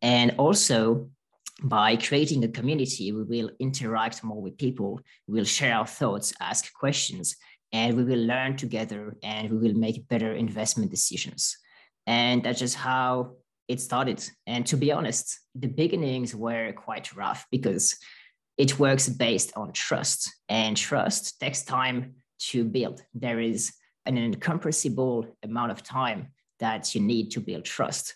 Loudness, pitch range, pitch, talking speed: -27 LUFS, 115-130 Hz, 120 Hz, 150 wpm